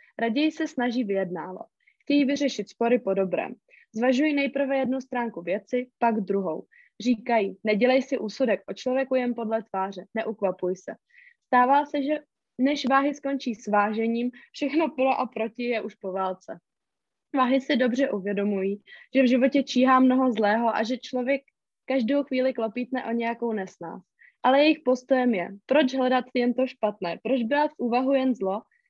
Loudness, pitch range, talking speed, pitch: -25 LUFS, 220-270 Hz, 160 wpm, 250 Hz